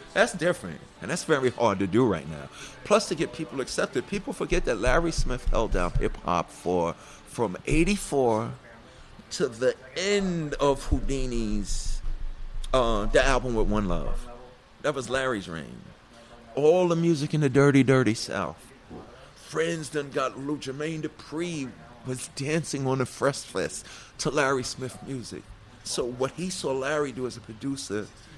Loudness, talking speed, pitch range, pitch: -27 LUFS, 160 wpm, 120-150 Hz, 135 Hz